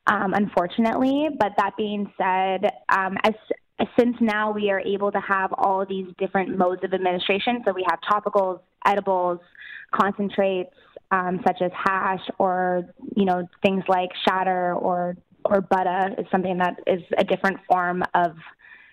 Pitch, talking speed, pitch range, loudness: 190 Hz, 155 wpm, 180-200 Hz, -23 LUFS